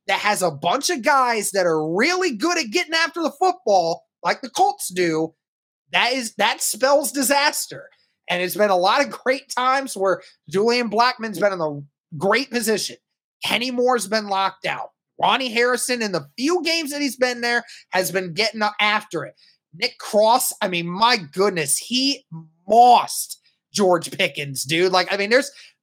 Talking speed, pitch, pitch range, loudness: 175 wpm, 220 Hz, 185-260 Hz, -20 LUFS